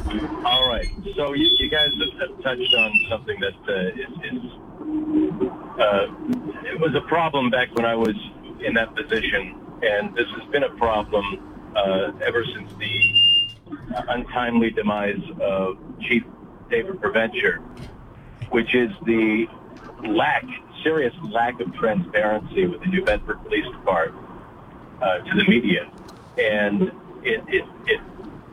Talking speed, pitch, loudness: 135 wpm, 125 Hz, -22 LUFS